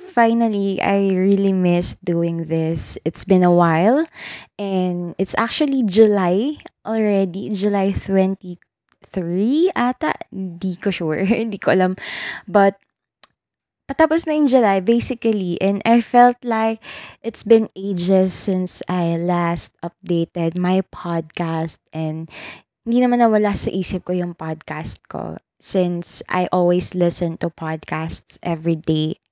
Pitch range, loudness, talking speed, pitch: 175-220 Hz, -19 LUFS, 125 wpm, 190 Hz